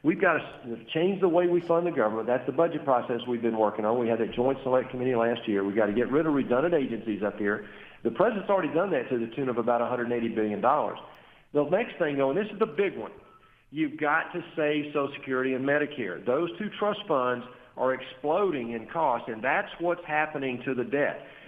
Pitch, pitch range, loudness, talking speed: 130 Hz, 120-160 Hz, -28 LUFS, 225 wpm